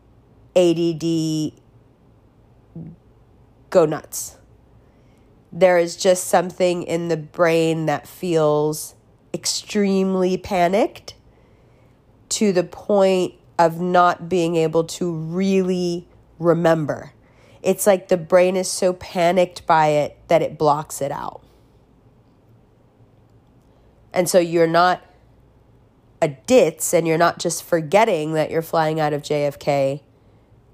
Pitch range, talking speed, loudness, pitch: 130-180 Hz, 105 wpm, -19 LUFS, 165 Hz